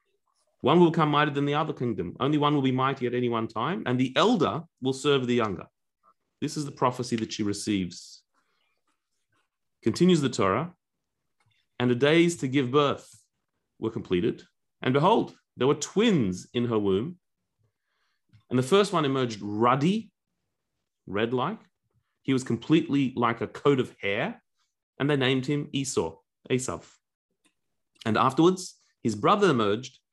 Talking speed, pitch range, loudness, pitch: 155 wpm, 115-145 Hz, -26 LUFS, 130 Hz